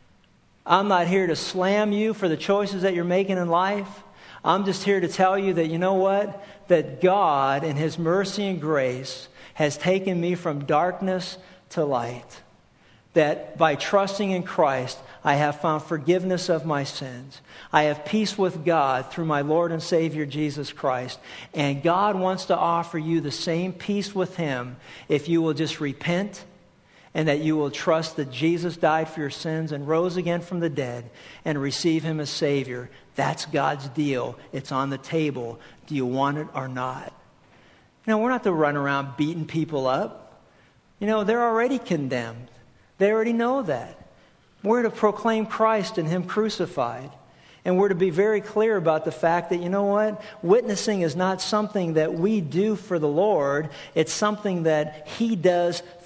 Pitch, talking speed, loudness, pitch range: 170 Hz, 185 wpm, -24 LUFS, 145-190 Hz